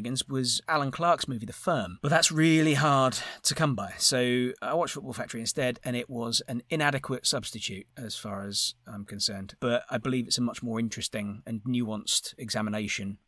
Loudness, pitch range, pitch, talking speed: -28 LUFS, 110-135 Hz, 120 Hz, 185 wpm